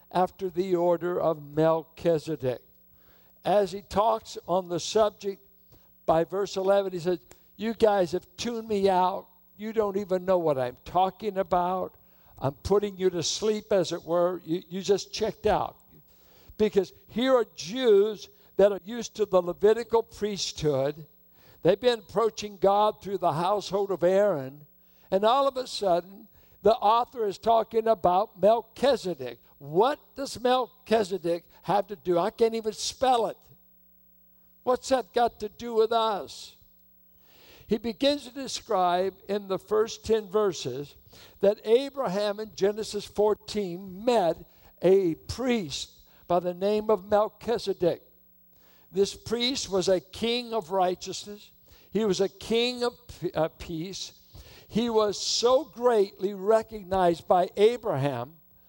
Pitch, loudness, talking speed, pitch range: 200 Hz, -27 LUFS, 135 wpm, 175-220 Hz